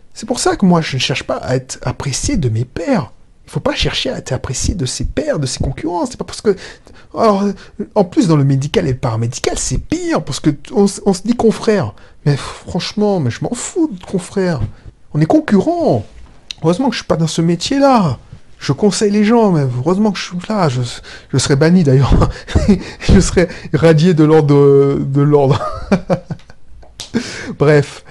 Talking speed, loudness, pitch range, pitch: 205 wpm, -15 LUFS, 135-205 Hz, 160 Hz